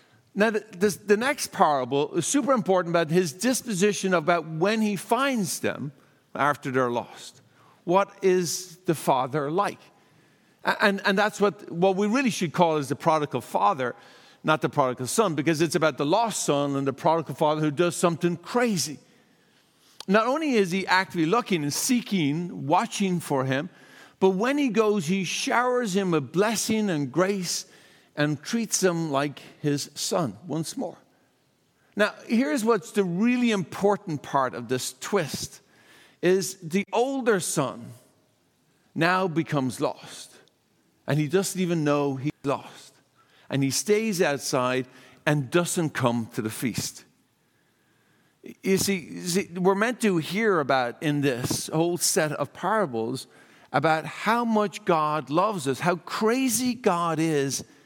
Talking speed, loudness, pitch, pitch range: 150 wpm, -25 LUFS, 175 Hz, 145-205 Hz